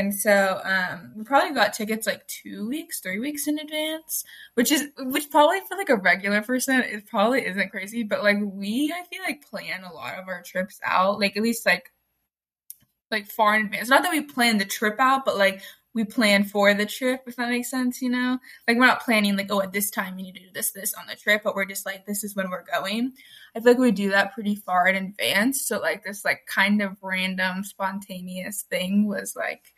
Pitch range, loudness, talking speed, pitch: 195-255 Hz, -23 LUFS, 235 wpm, 210 Hz